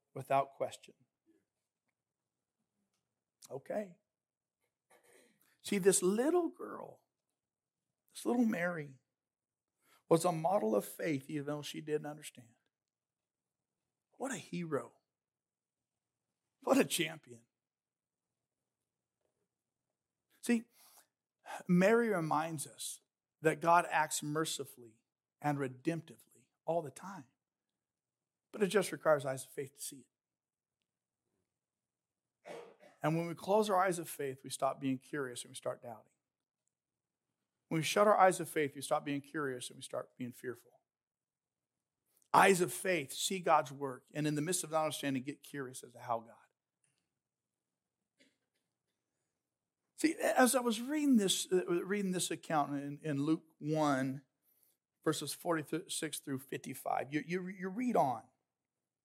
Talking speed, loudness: 125 wpm, -35 LUFS